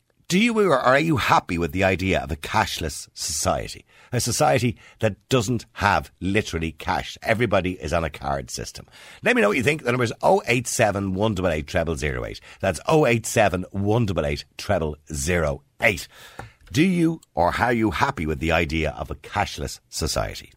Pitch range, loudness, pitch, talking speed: 80-120 Hz, -23 LUFS, 100 Hz, 155 wpm